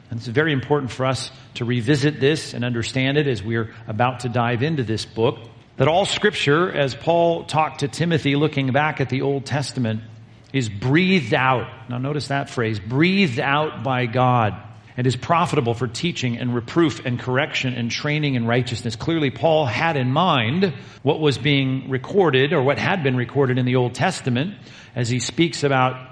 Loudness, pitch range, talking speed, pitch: -21 LUFS, 120-150 Hz, 185 wpm, 130 Hz